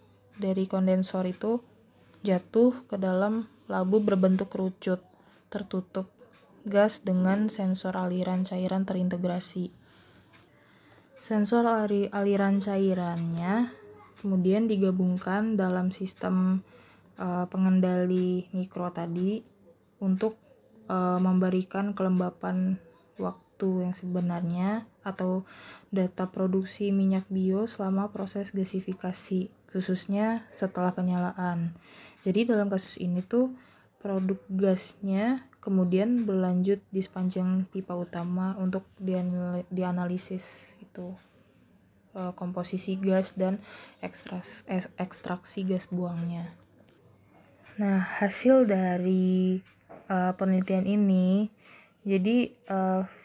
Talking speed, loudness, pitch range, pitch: 85 wpm, -29 LUFS, 185-200 Hz, 190 Hz